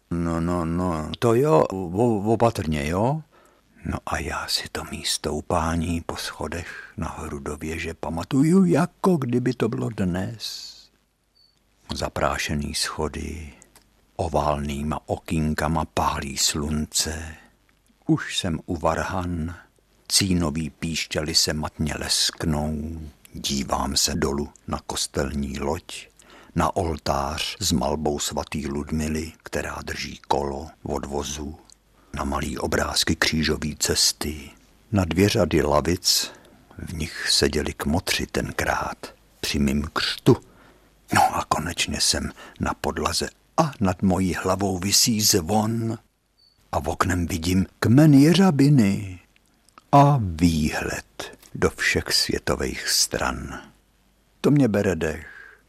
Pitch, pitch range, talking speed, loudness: 80 Hz, 75-95 Hz, 110 wpm, -23 LUFS